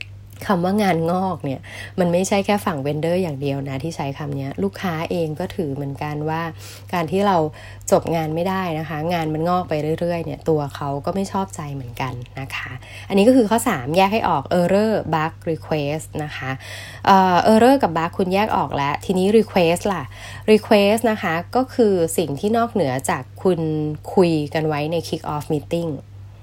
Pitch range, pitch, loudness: 140-190 Hz, 165 Hz, -20 LUFS